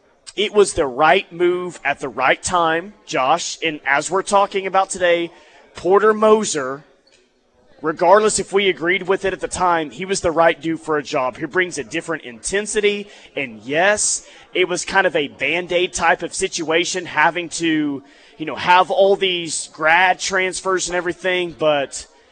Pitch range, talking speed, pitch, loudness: 155-190 Hz, 170 wpm, 175 Hz, -18 LUFS